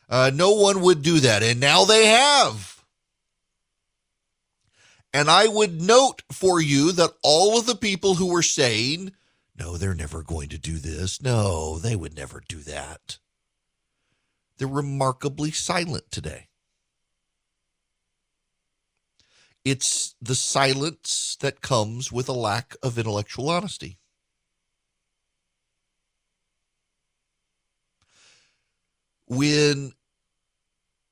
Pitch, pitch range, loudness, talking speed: 135 Hz, 105-170 Hz, -20 LUFS, 100 wpm